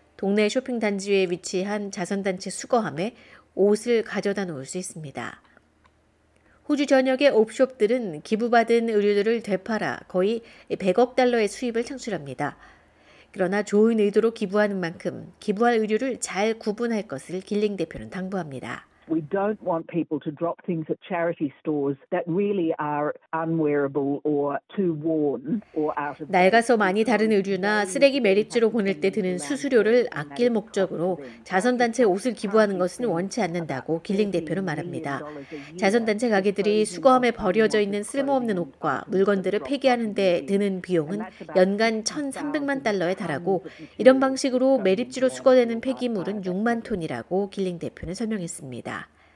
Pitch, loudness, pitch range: 200 Hz, -24 LUFS, 170-225 Hz